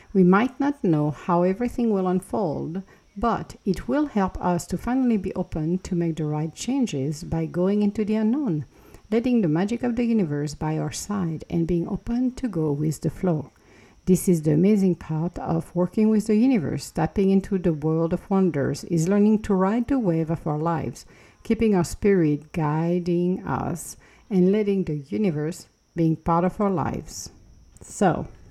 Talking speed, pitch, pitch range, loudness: 175 wpm, 180 Hz, 160-210 Hz, -24 LUFS